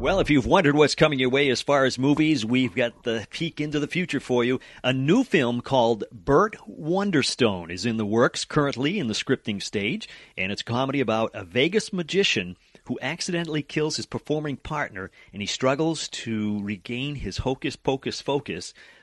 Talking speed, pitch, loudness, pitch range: 185 wpm, 130 Hz, -24 LUFS, 115-150 Hz